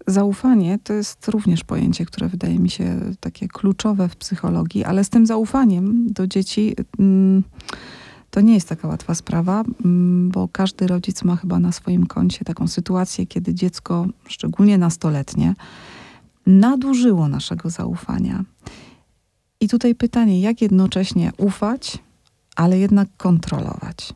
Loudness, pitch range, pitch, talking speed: -19 LUFS, 180-215 Hz, 190 Hz, 125 wpm